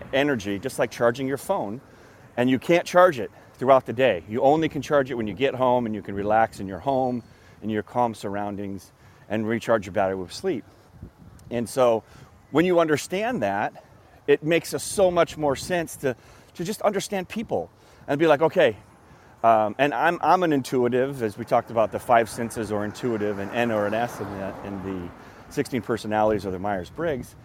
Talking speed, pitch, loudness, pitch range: 200 wpm, 120 Hz, -24 LUFS, 105-140 Hz